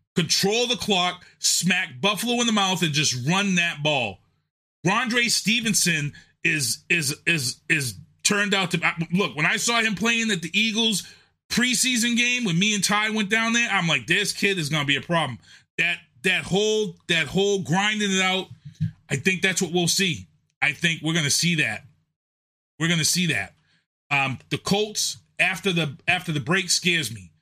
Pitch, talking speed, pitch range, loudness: 175 Hz, 180 wpm, 155-200 Hz, -22 LUFS